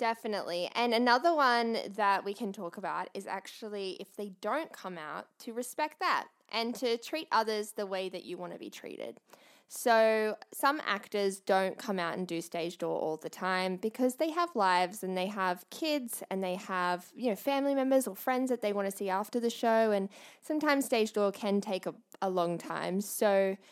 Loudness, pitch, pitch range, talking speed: -32 LUFS, 210 Hz, 190-240 Hz, 200 wpm